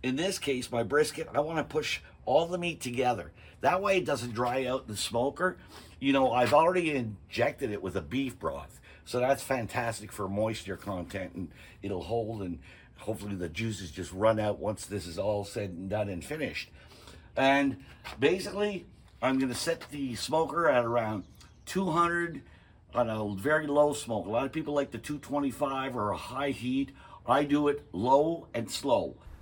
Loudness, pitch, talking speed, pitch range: -30 LUFS, 125 Hz, 180 wpm, 100-145 Hz